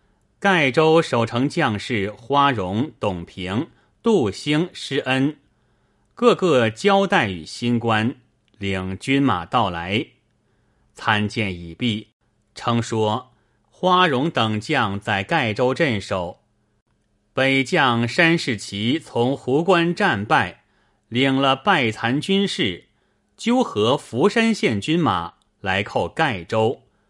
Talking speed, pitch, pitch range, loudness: 150 characters per minute, 120 Hz, 105-145 Hz, -20 LUFS